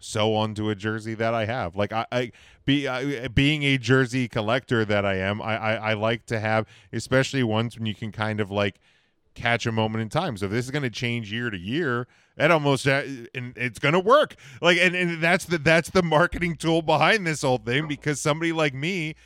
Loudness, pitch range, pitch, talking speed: -24 LUFS, 110-145 Hz, 125 Hz, 225 wpm